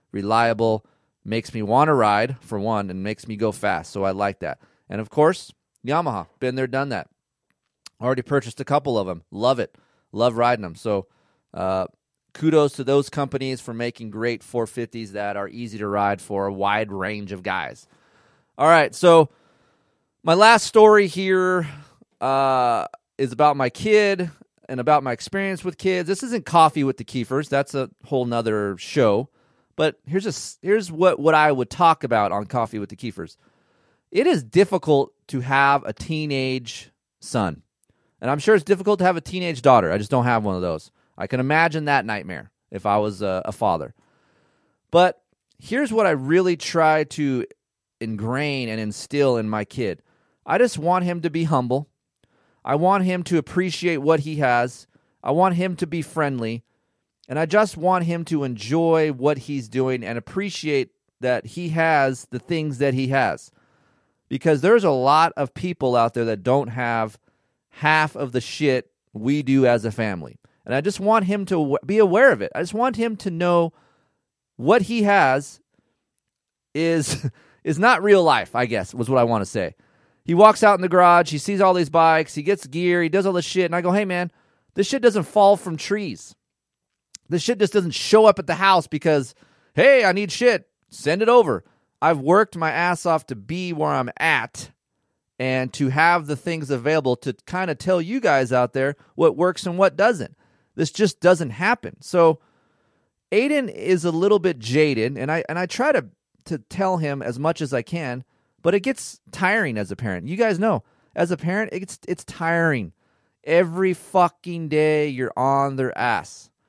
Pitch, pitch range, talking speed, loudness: 150 Hz, 125-180 Hz, 190 wpm, -21 LUFS